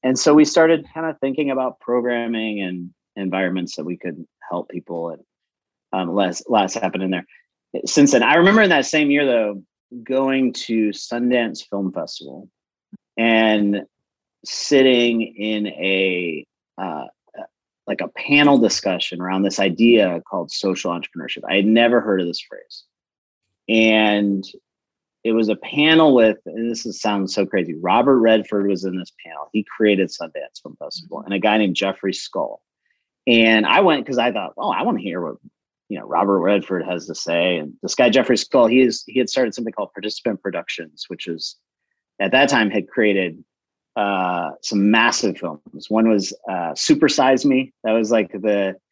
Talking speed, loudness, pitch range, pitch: 175 wpm, -18 LUFS, 95-125 Hz, 110 Hz